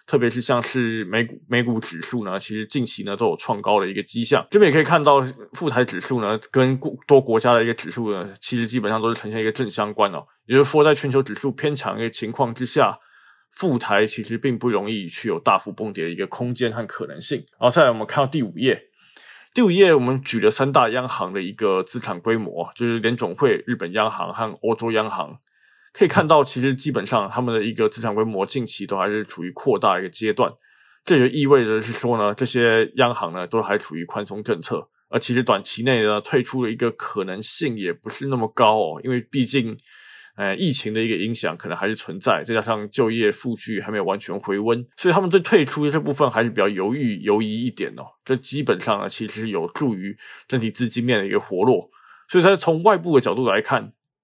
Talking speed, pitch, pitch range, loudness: 335 characters per minute, 115 Hz, 110-130 Hz, -21 LUFS